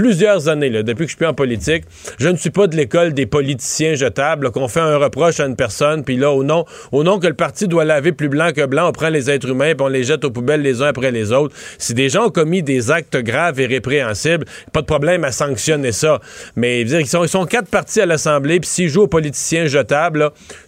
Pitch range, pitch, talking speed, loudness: 135-170 Hz, 150 Hz, 265 wpm, -16 LUFS